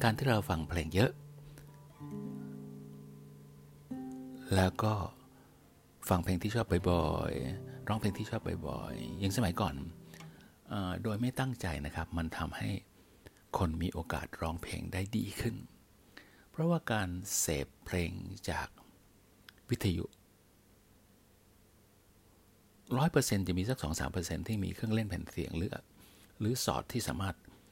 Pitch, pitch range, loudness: 100 Hz, 85-115 Hz, -35 LUFS